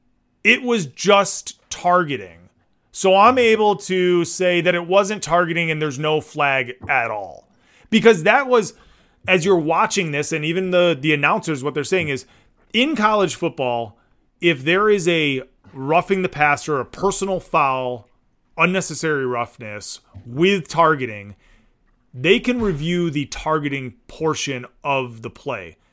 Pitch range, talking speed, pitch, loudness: 130-190 Hz, 140 wpm, 160 Hz, -19 LUFS